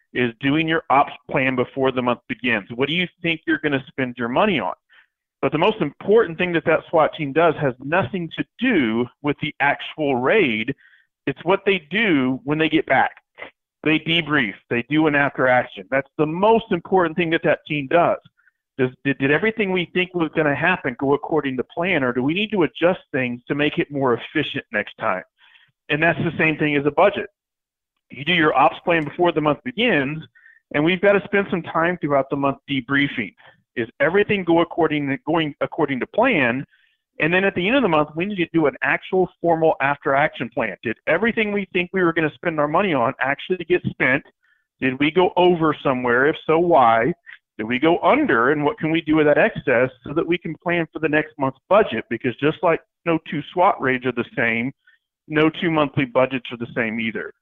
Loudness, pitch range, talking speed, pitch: -20 LUFS, 140-175 Hz, 215 wpm, 155 Hz